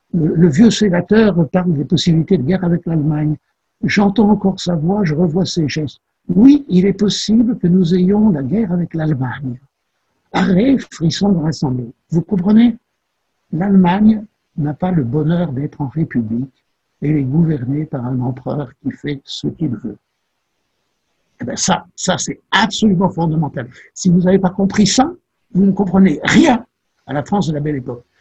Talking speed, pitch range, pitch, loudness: 170 wpm, 150-200 Hz, 175 Hz, -15 LUFS